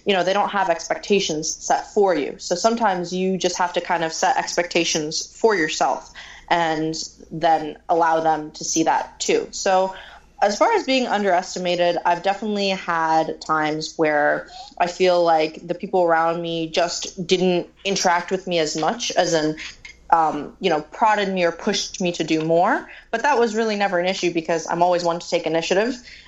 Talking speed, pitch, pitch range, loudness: 185 wpm, 175 Hz, 165-195 Hz, -21 LUFS